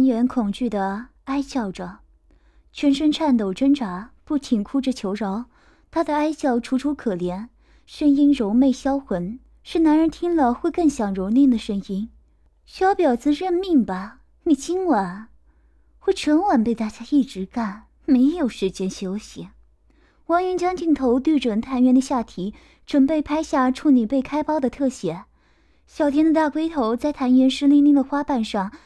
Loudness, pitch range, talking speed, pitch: -21 LUFS, 225-300 Hz, 230 characters per minute, 265 Hz